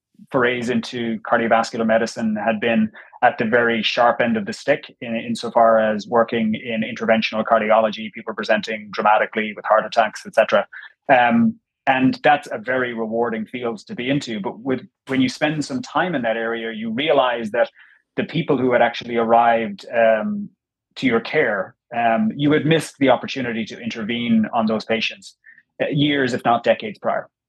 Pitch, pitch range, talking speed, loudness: 120 Hz, 115-140 Hz, 170 wpm, -20 LUFS